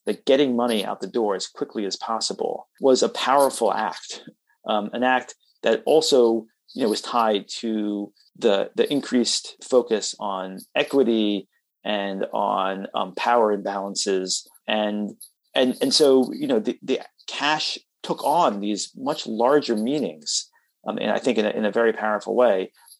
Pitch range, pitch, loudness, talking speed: 100-120 Hz, 105 Hz, -23 LUFS, 160 wpm